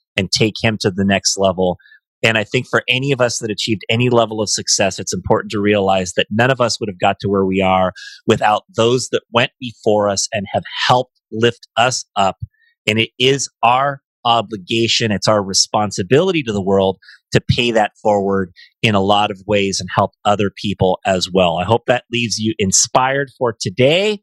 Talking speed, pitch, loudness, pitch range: 200 wpm, 110 Hz, -16 LUFS, 100-120 Hz